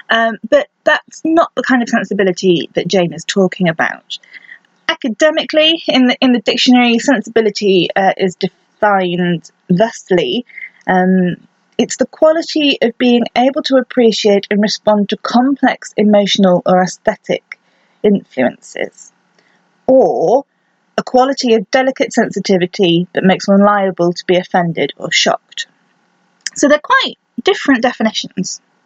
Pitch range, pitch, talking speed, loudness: 190-260 Hz, 220 Hz, 125 wpm, -13 LUFS